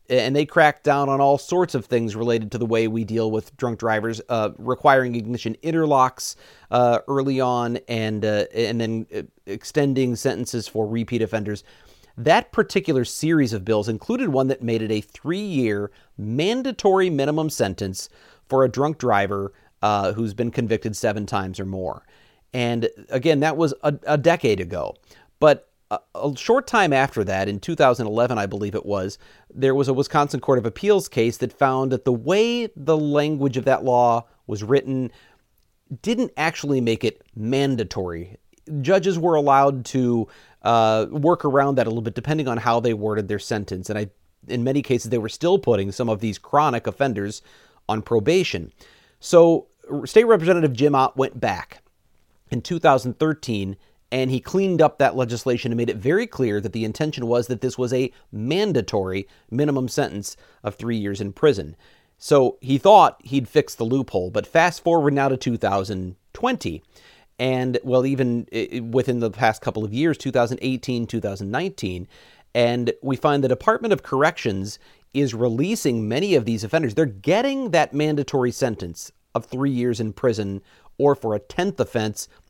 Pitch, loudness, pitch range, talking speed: 125 Hz, -21 LUFS, 110-145 Hz, 165 wpm